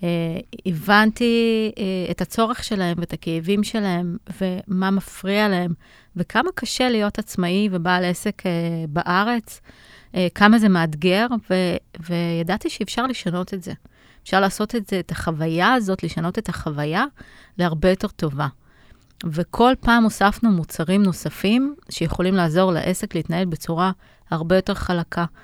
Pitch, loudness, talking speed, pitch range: 185 Hz, -21 LUFS, 130 wpm, 170-210 Hz